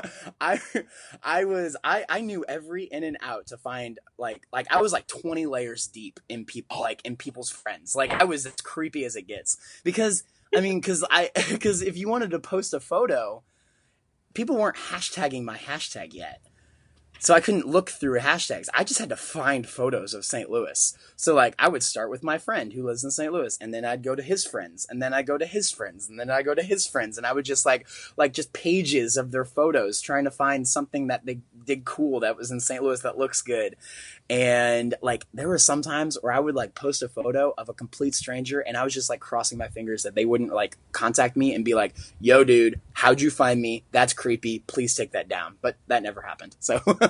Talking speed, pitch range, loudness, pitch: 230 wpm, 120-165 Hz, -25 LUFS, 135 Hz